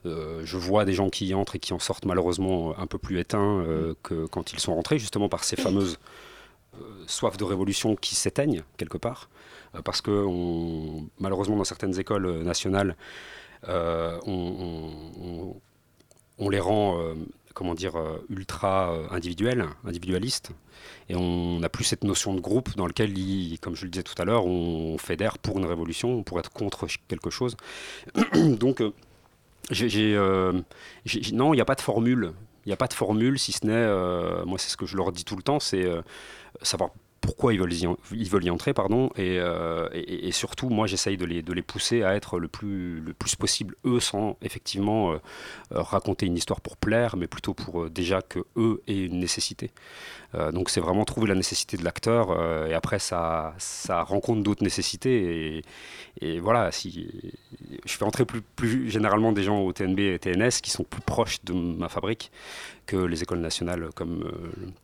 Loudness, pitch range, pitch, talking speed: -27 LUFS, 85-105 Hz, 95 Hz, 195 wpm